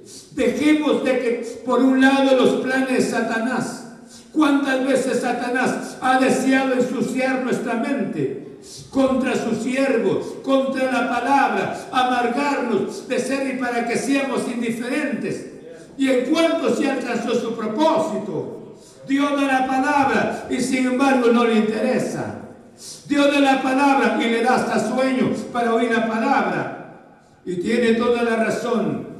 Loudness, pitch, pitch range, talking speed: -20 LUFS, 250 Hz, 235-265 Hz, 140 wpm